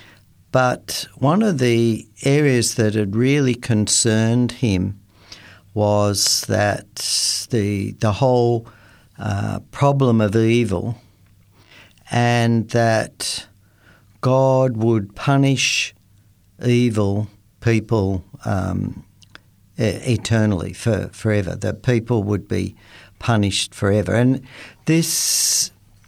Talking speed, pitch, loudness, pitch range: 85 wpm, 110 Hz, -19 LUFS, 100-120 Hz